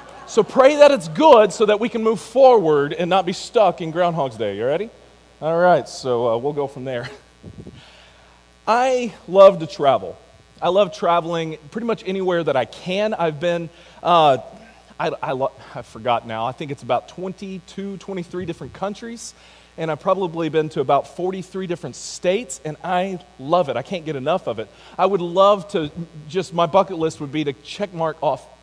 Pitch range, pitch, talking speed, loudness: 150-190 Hz, 175 Hz, 190 wpm, -19 LUFS